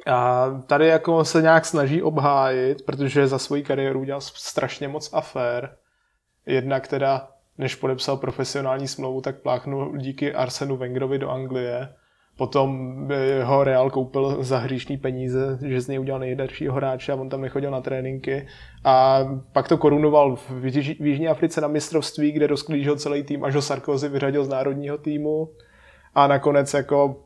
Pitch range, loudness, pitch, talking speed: 130-145 Hz, -22 LUFS, 135 Hz, 155 wpm